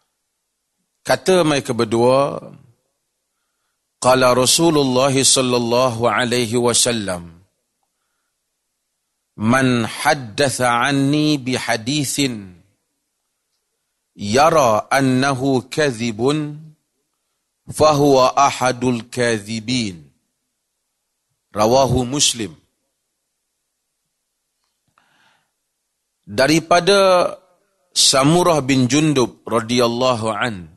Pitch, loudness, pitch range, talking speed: 125 Hz, -16 LUFS, 120-140 Hz, 55 wpm